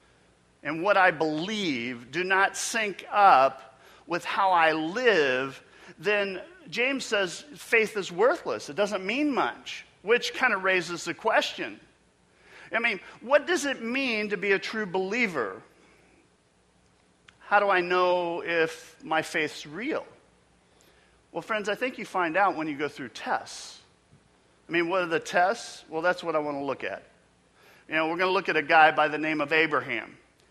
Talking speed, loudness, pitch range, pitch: 170 wpm, -26 LUFS, 145-205 Hz, 170 Hz